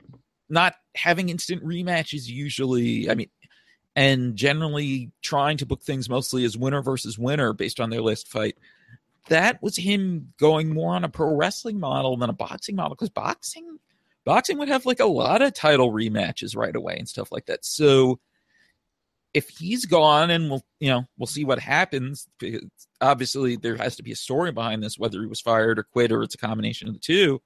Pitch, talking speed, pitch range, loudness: 140 Hz, 190 wpm, 125-170 Hz, -23 LUFS